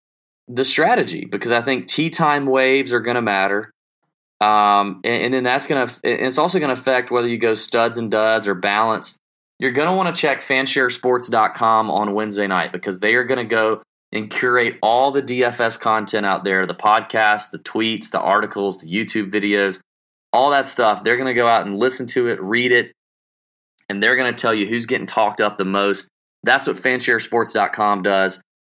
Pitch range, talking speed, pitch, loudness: 105-125 Hz, 195 wpm, 115 Hz, -18 LUFS